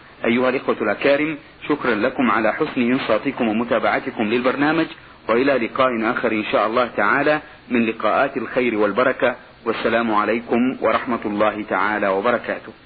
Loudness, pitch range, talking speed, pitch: -20 LUFS, 110-145 Hz, 125 wpm, 125 Hz